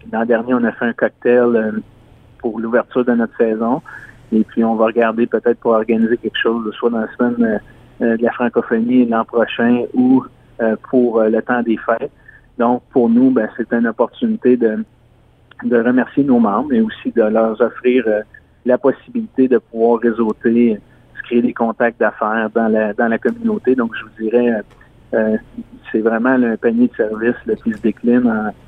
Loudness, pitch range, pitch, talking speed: -16 LUFS, 115-125 Hz, 120 Hz, 175 wpm